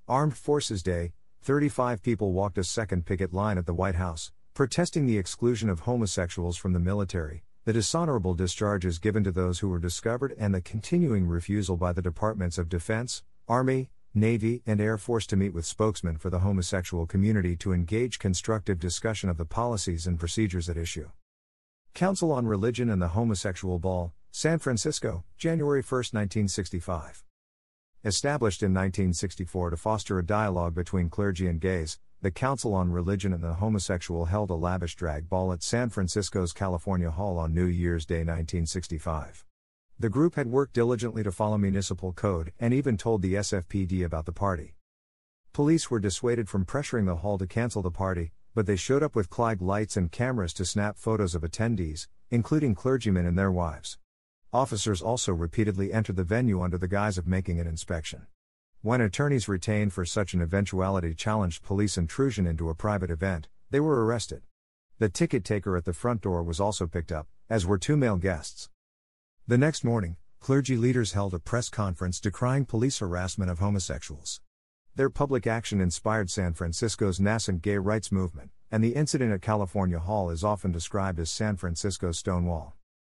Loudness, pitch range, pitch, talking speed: -28 LUFS, 90-110 Hz, 95 Hz, 175 wpm